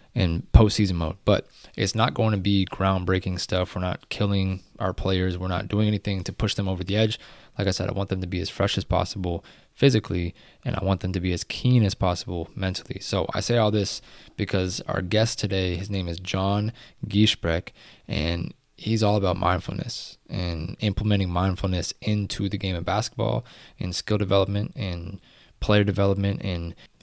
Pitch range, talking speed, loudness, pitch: 90-105 Hz, 185 wpm, -25 LUFS, 95 Hz